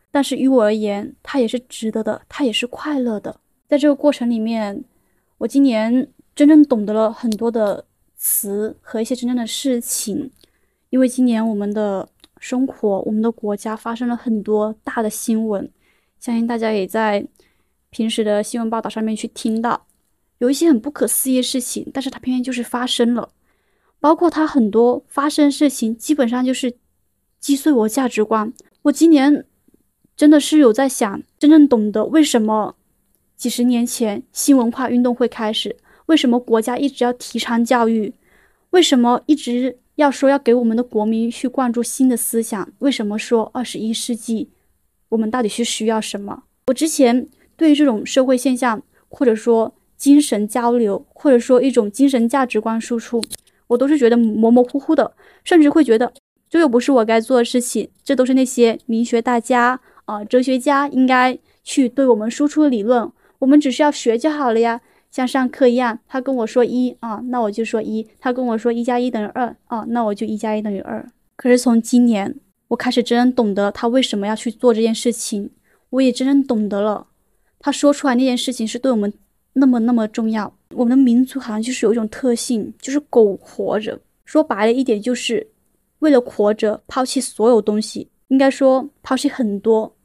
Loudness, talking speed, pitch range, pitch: -17 LUFS, 280 characters per minute, 225-265 Hz, 245 Hz